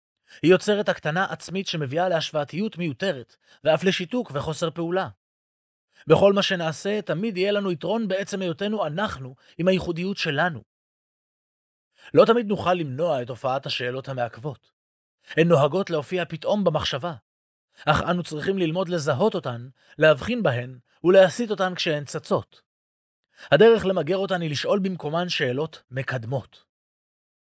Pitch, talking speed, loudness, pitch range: 170 Hz, 125 wpm, -23 LUFS, 145-190 Hz